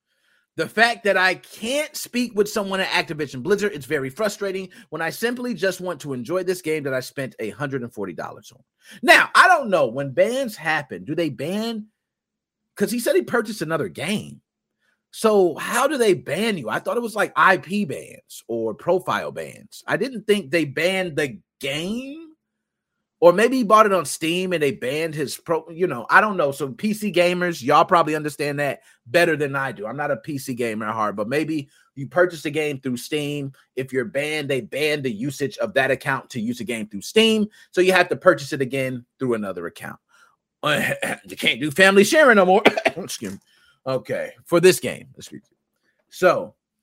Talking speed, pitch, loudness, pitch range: 190 wpm, 175 Hz, -21 LUFS, 140-205 Hz